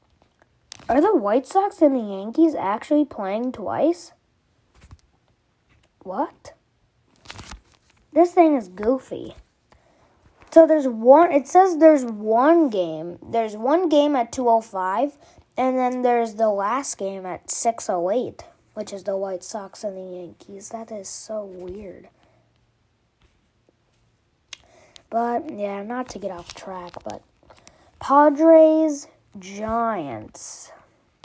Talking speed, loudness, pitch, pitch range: 110 wpm, -20 LUFS, 225 Hz, 195-290 Hz